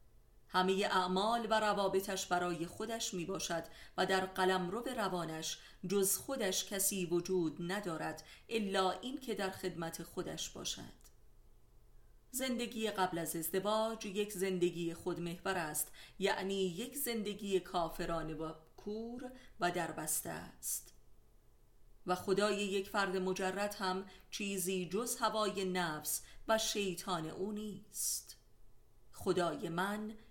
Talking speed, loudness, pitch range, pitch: 115 wpm, -37 LUFS, 175-205 Hz, 190 Hz